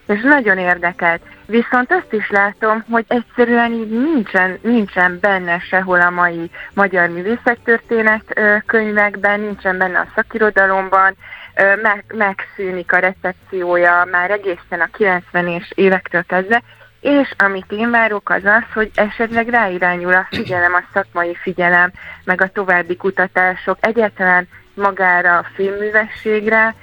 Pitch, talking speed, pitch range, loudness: 195 Hz, 125 wpm, 180-220 Hz, -15 LUFS